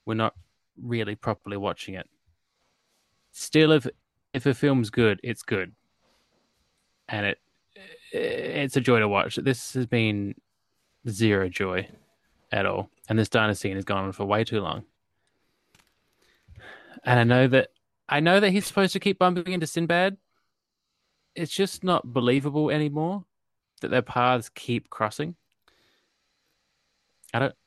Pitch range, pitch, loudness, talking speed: 110-155 Hz, 125 Hz, -25 LUFS, 140 wpm